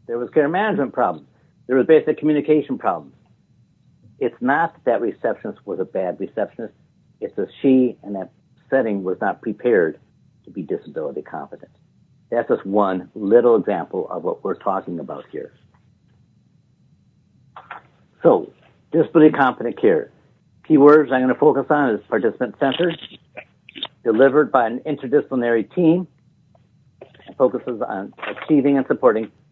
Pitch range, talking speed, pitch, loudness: 125-155 Hz, 135 wpm, 140 Hz, -19 LUFS